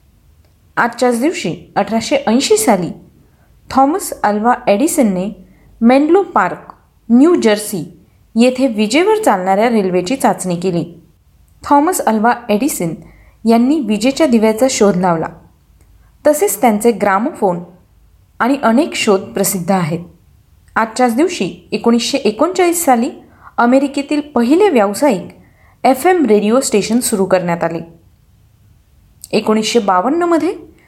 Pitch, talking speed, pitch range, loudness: 230 Hz, 100 wpm, 190-275 Hz, -14 LUFS